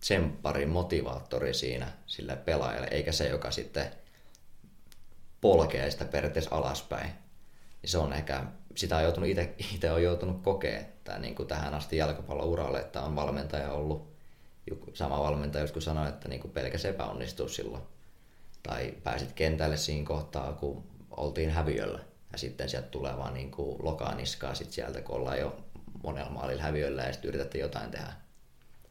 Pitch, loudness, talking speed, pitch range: 75 Hz, -33 LUFS, 140 wpm, 70-80 Hz